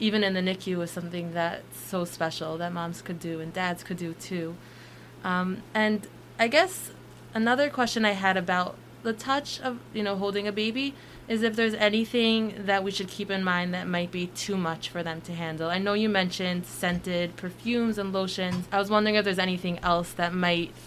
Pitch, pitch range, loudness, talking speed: 185 Hz, 175-215 Hz, -28 LUFS, 205 wpm